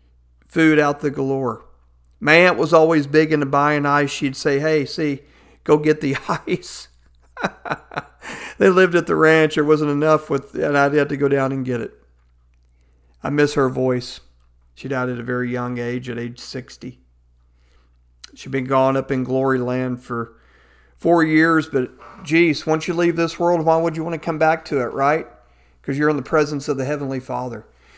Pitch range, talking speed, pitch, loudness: 115-155 Hz, 190 wpm, 135 Hz, -19 LUFS